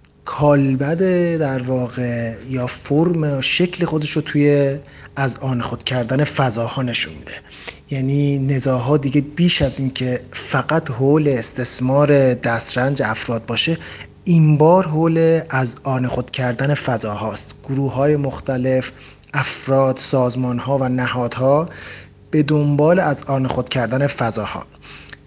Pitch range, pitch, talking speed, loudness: 125-145 Hz, 135 Hz, 125 wpm, -17 LUFS